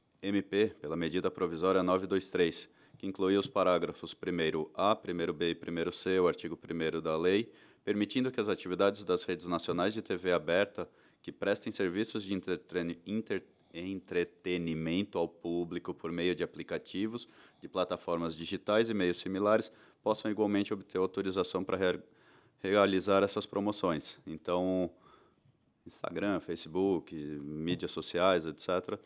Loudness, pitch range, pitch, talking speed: -33 LUFS, 85-100 Hz, 95 Hz, 125 wpm